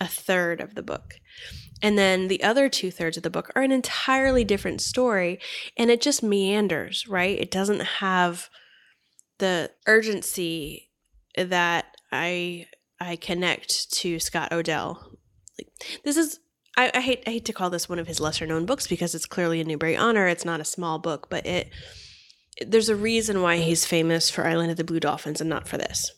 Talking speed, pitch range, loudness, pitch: 190 wpm, 165-220 Hz, -24 LUFS, 180 Hz